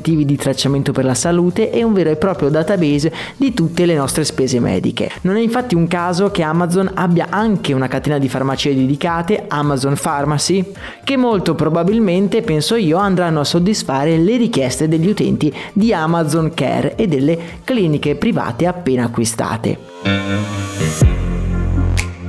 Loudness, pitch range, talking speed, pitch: -16 LUFS, 135-185 Hz, 145 wpm, 160 Hz